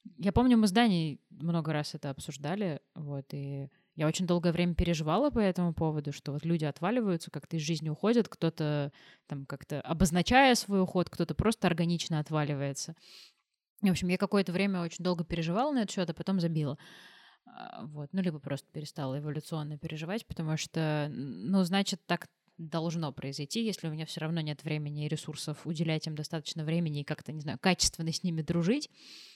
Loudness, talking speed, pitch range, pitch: -32 LUFS, 175 wpm, 150-185 Hz, 165 Hz